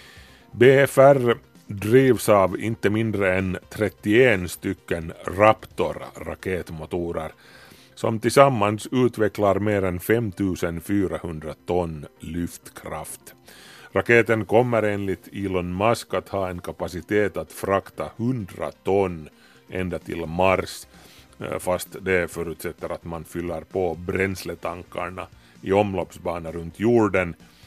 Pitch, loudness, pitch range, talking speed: 95 Hz, -23 LUFS, 85-105 Hz, 100 wpm